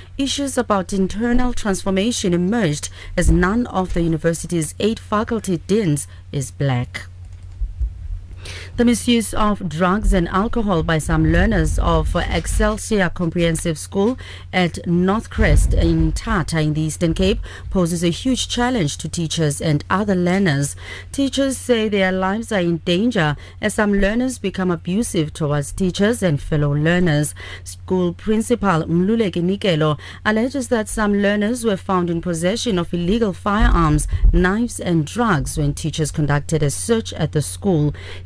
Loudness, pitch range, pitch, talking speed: -19 LUFS, 150-210 Hz, 180 Hz, 140 wpm